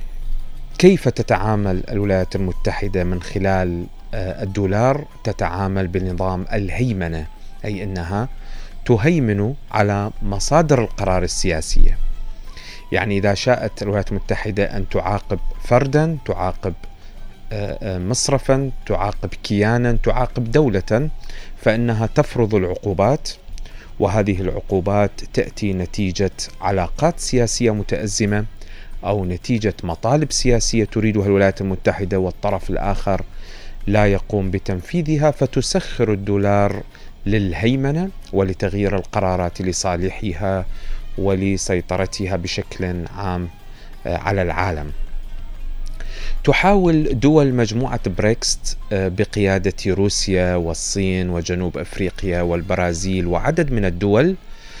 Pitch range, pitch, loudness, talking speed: 95-110 Hz, 100 Hz, -20 LUFS, 85 wpm